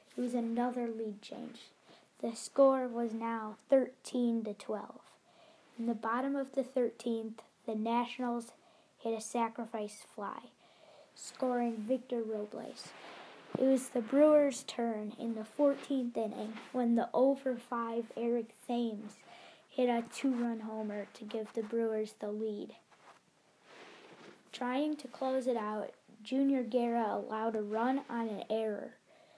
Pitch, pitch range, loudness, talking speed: 235 Hz, 220-255 Hz, -35 LUFS, 130 wpm